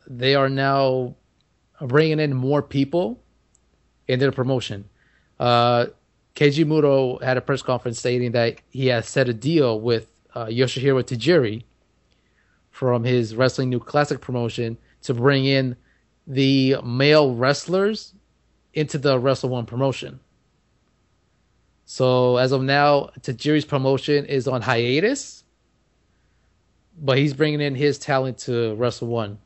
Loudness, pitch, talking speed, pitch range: -21 LUFS, 130 Hz, 130 wpm, 120-140 Hz